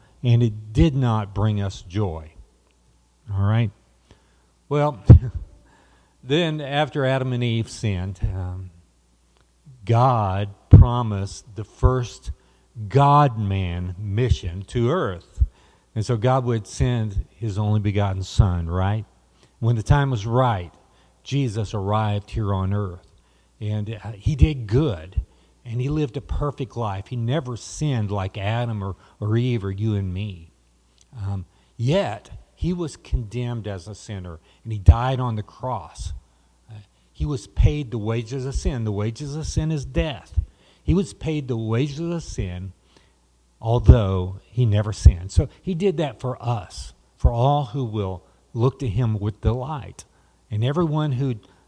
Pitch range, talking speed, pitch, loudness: 90-125 Hz, 145 wpm, 105 Hz, -23 LUFS